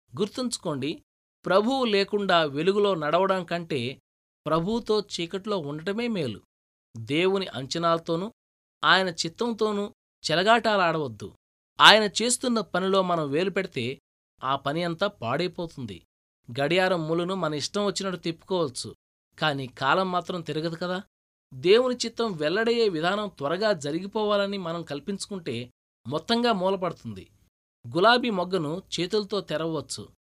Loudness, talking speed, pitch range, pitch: -25 LUFS, 95 wpm, 150-205 Hz, 180 Hz